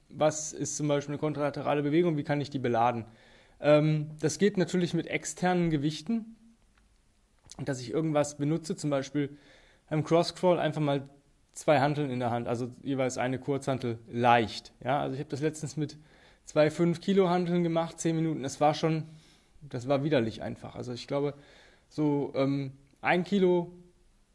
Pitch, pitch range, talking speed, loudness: 145 Hz, 135-160 Hz, 165 wpm, -29 LUFS